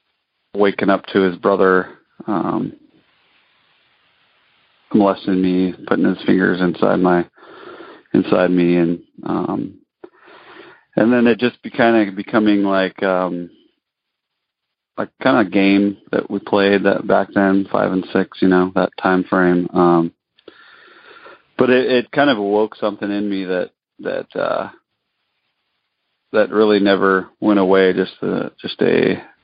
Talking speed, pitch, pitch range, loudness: 135 wpm, 95 Hz, 90-105 Hz, -17 LUFS